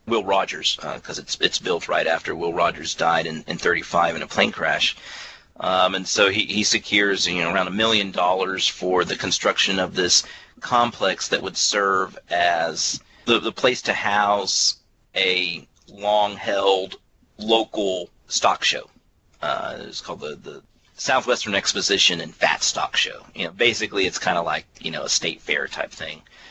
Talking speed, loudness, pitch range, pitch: 175 wpm, -21 LUFS, 90-105 Hz, 95 Hz